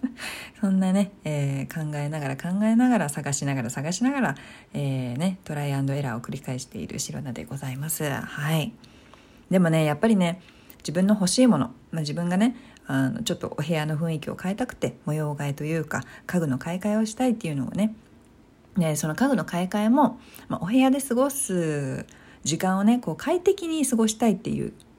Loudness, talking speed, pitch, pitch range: -25 LUFS, 385 characters per minute, 175 Hz, 150-225 Hz